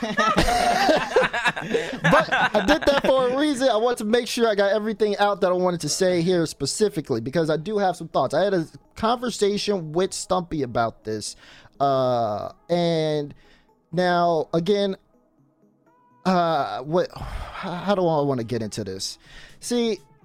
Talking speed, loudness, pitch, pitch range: 155 wpm, -22 LUFS, 180 Hz, 150-215 Hz